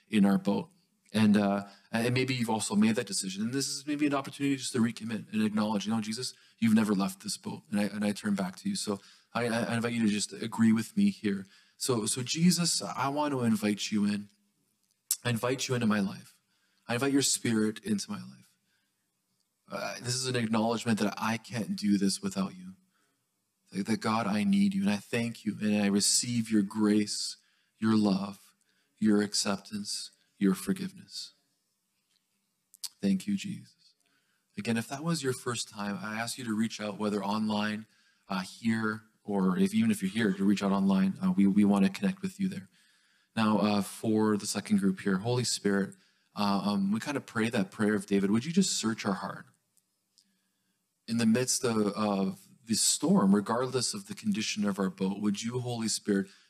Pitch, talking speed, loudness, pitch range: 110 Hz, 200 wpm, -30 LUFS, 100-130 Hz